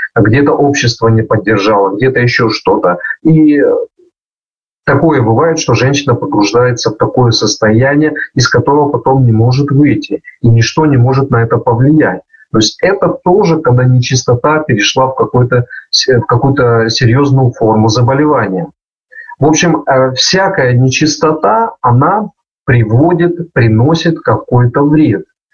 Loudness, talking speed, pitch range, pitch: -9 LUFS, 120 wpm, 120-155 Hz, 135 Hz